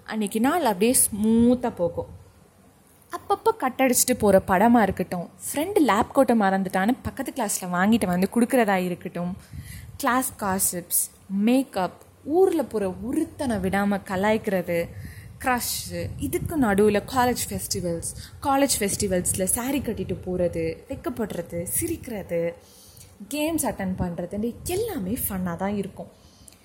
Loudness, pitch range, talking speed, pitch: -24 LUFS, 185-250 Hz, 105 wpm, 205 Hz